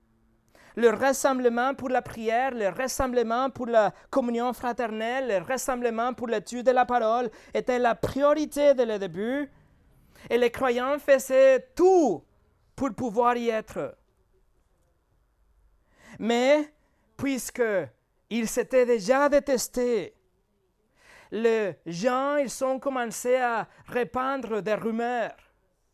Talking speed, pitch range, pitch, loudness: 110 wpm, 230-265 Hz, 245 Hz, -26 LUFS